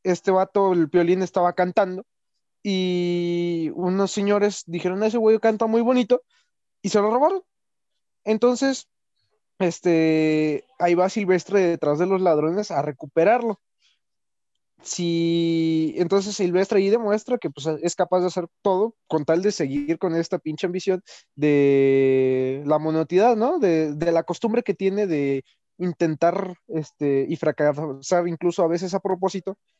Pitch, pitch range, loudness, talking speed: 180 Hz, 160-200 Hz, -22 LUFS, 140 wpm